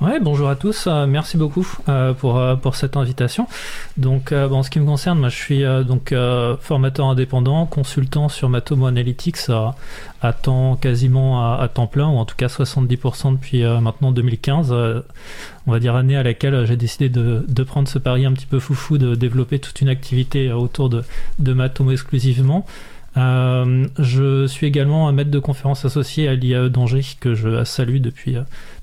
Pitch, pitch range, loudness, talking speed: 130 Hz, 125-140 Hz, -18 LUFS, 200 wpm